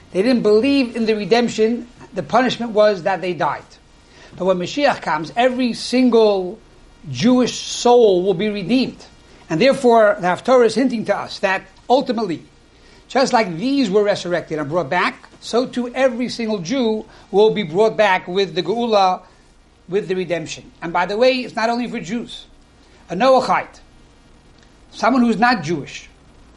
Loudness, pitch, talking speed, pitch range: -18 LUFS, 220 Hz, 160 wpm, 190-245 Hz